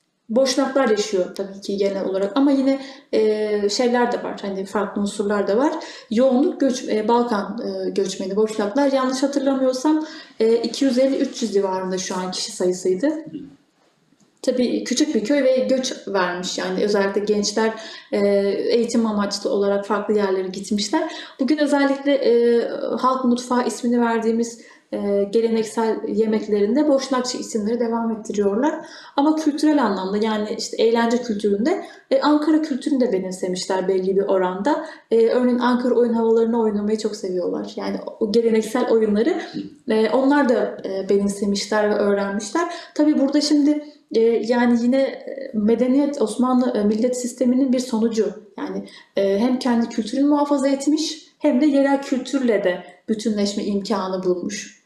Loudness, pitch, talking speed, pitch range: -20 LUFS, 235 Hz, 135 wpm, 205-275 Hz